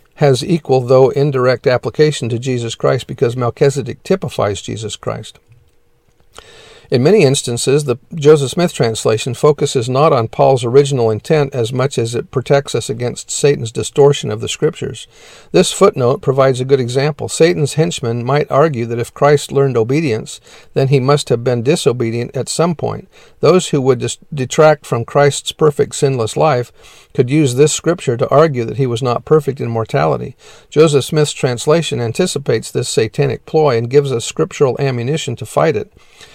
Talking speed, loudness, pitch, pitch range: 165 wpm, -14 LUFS, 140 Hz, 120-150 Hz